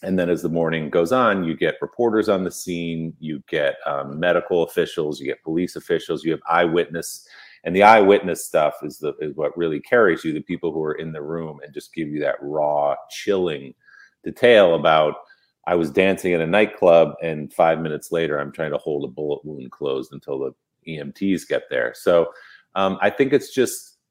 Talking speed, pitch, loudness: 200 wpm, 90 Hz, -21 LUFS